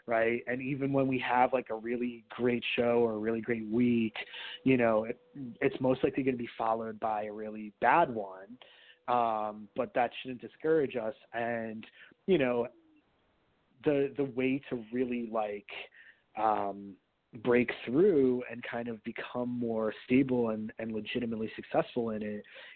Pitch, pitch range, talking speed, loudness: 120 Hz, 110-130 Hz, 160 wpm, -32 LUFS